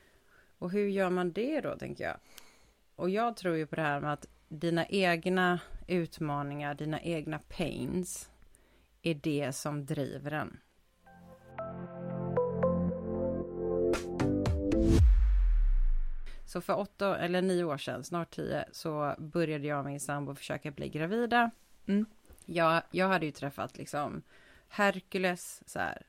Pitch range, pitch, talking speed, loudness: 140-180 Hz, 160 Hz, 125 wpm, -33 LUFS